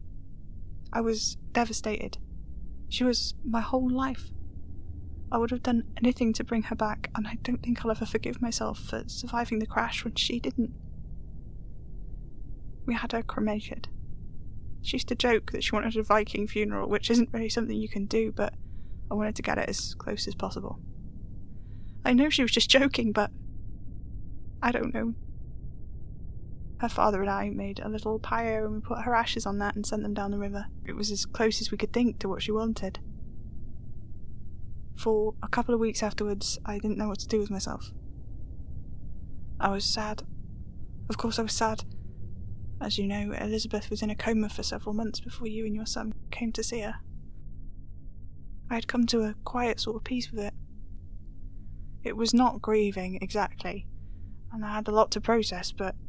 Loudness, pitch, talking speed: -29 LUFS, 205 Hz, 185 wpm